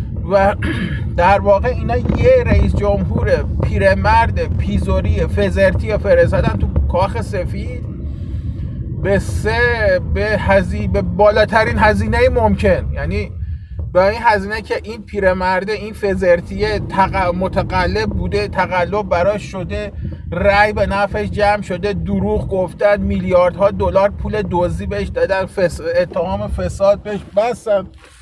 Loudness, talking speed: -16 LUFS, 110 wpm